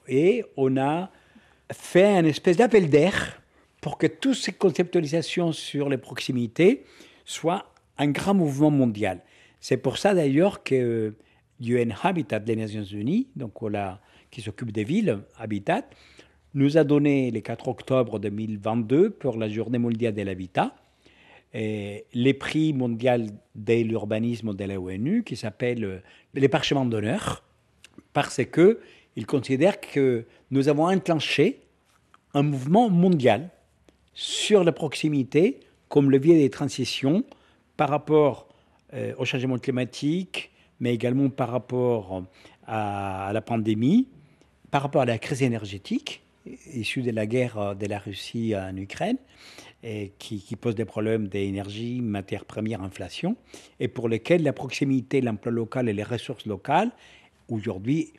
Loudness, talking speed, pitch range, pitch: -25 LUFS, 135 wpm, 110-145 Hz, 125 Hz